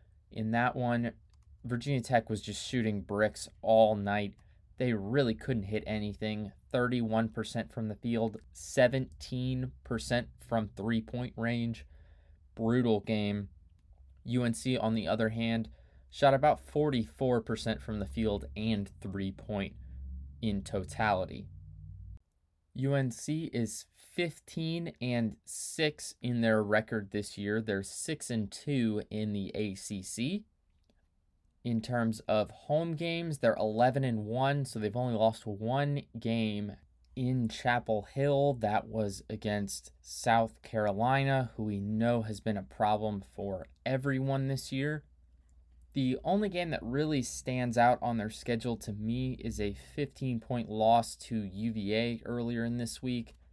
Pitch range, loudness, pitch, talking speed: 100-125 Hz, -33 LUFS, 110 Hz, 130 wpm